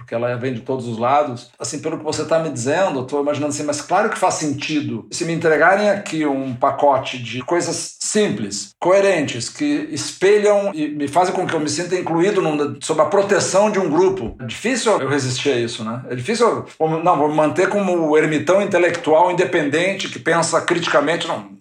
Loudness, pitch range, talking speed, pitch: -18 LUFS, 140-180 Hz, 205 wpm, 155 Hz